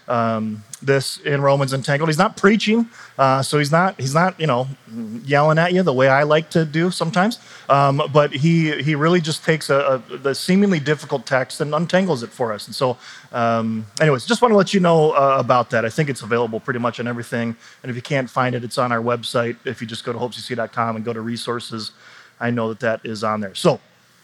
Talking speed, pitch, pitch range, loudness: 230 wpm, 135 Hz, 120-160 Hz, -19 LUFS